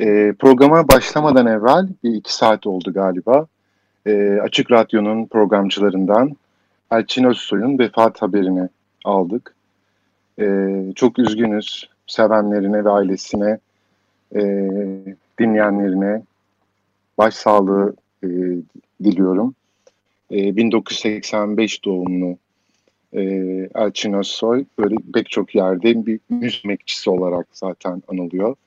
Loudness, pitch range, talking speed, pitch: -17 LUFS, 95-110 Hz, 75 wpm, 105 Hz